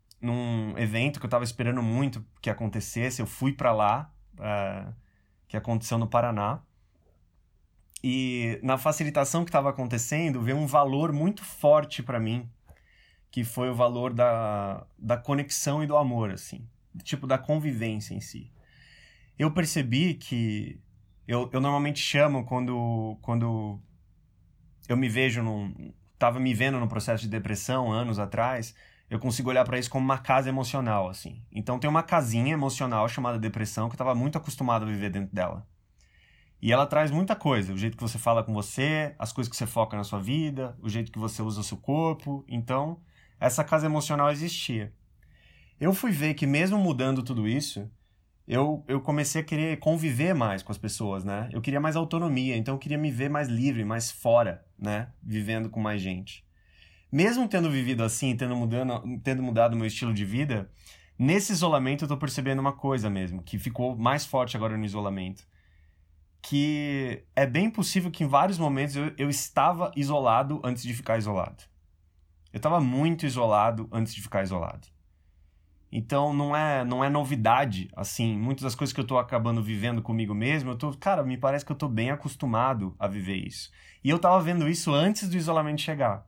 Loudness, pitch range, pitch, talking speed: -28 LUFS, 110-145 Hz, 120 Hz, 175 wpm